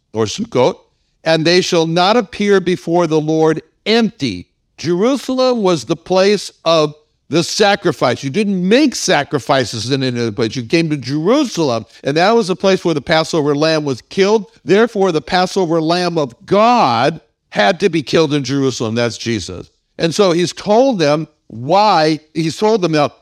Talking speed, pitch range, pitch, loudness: 170 wpm, 145-195 Hz, 165 Hz, -15 LUFS